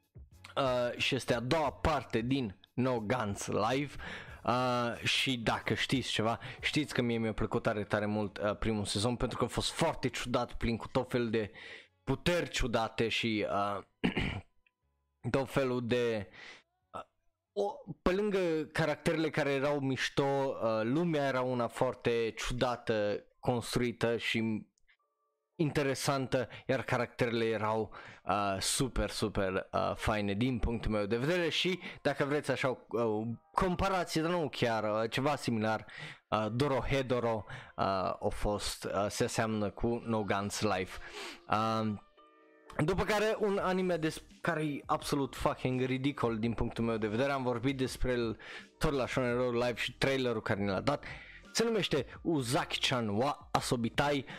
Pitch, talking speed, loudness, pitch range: 125 Hz, 145 wpm, -33 LUFS, 110-140 Hz